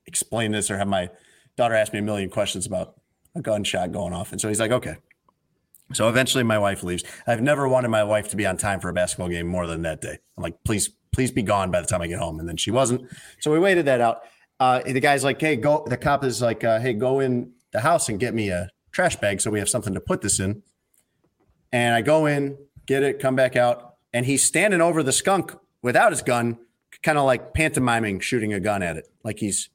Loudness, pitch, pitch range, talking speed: -22 LUFS, 120 Hz, 105-130 Hz, 250 wpm